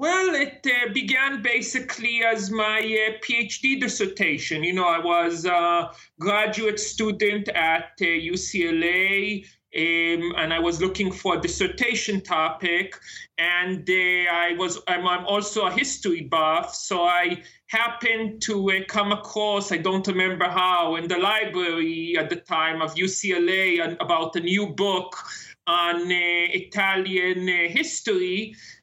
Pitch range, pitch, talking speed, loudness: 175-215 Hz, 185 Hz, 135 wpm, -23 LUFS